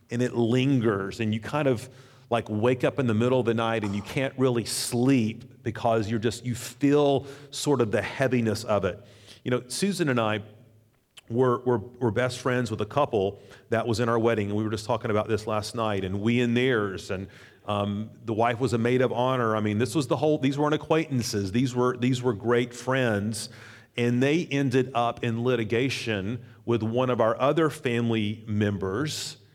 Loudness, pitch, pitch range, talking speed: -26 LUFS, 120 Hz, 110-130 Hz, 205 wpm